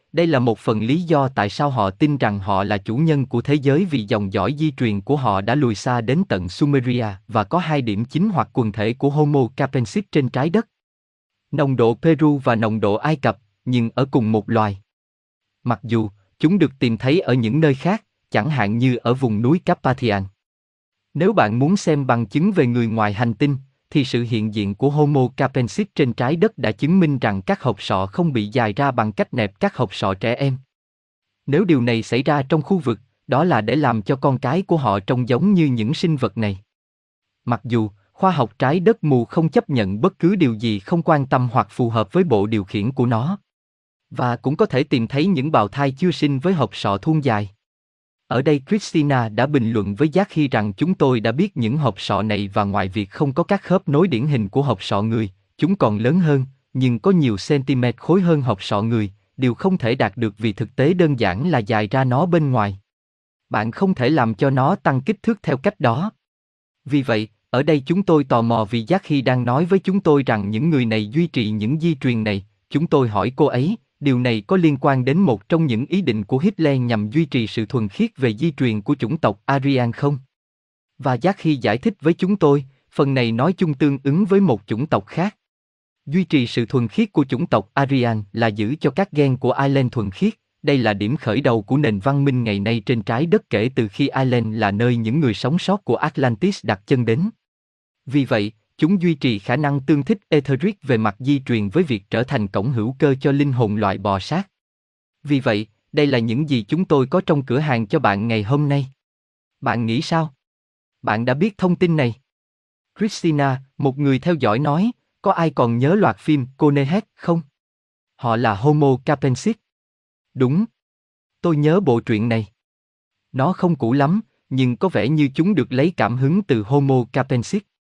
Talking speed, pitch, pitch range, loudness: 220 wpm, 130 Hz, 110-155 Hz, -19 LUFS